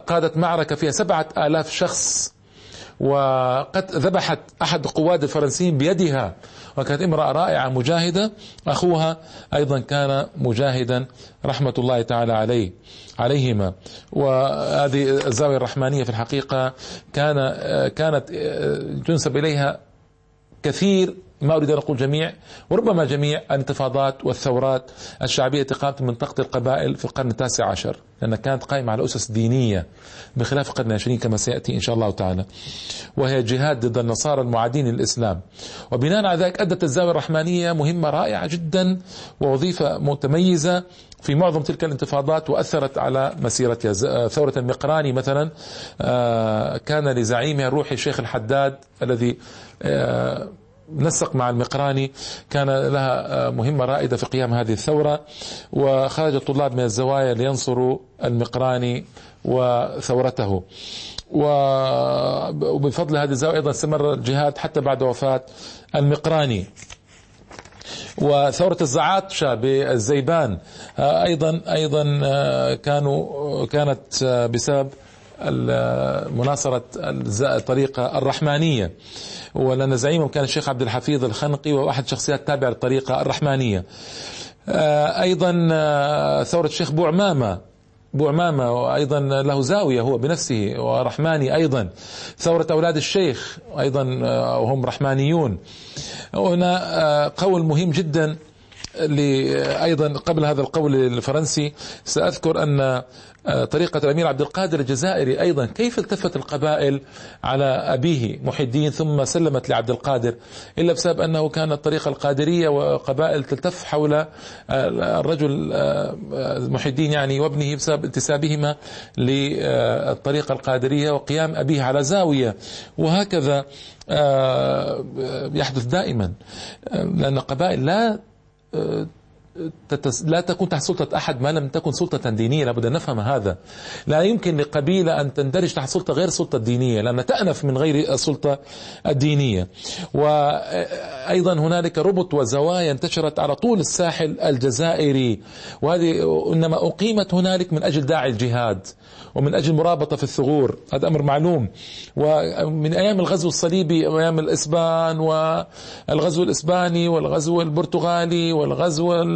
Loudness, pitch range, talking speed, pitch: -21 LUFS, 125-160 Hz, 110 wpm, 145 Hz